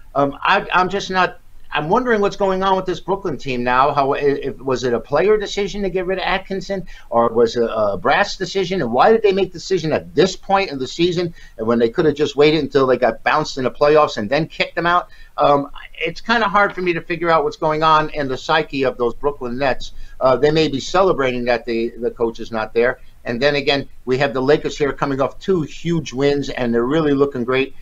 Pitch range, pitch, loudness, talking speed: 130-180 Hz, 150 Hz, -18 LUFS, 250 wpm